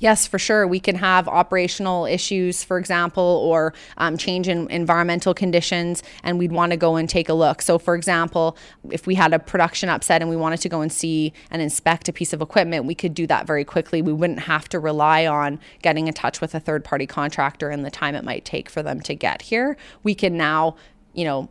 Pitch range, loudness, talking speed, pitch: 160-180 Hz, -21 LUFS, 230 wpm, 170 Hz